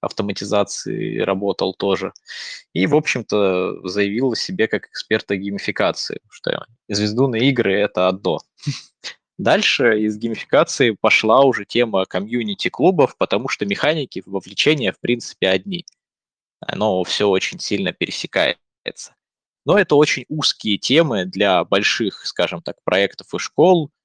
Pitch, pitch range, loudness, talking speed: 105 Hz, 100-135 Hz, -19 LUFS, 125 wpm